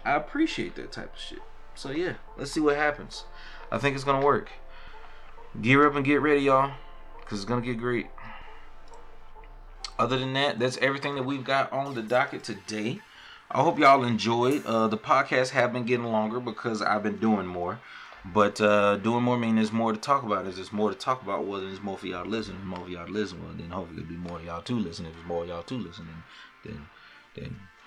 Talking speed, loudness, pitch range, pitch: 215 wpm, -27 LUFS, 95-130 Hz, 115 Hz